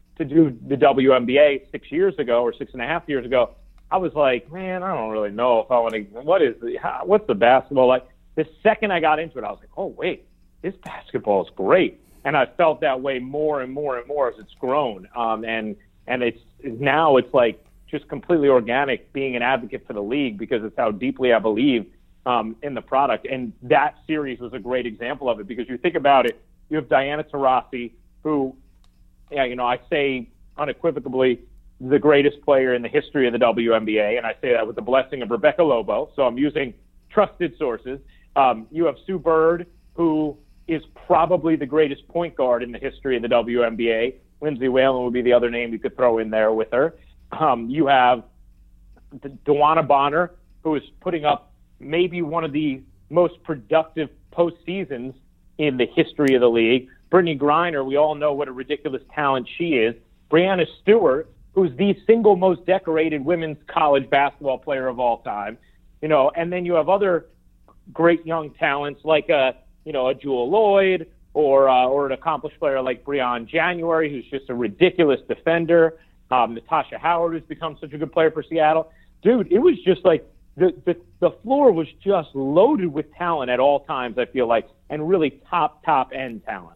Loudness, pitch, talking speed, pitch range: -21 LUFS, 145 Hz, 195 wpm, 125-165 Hz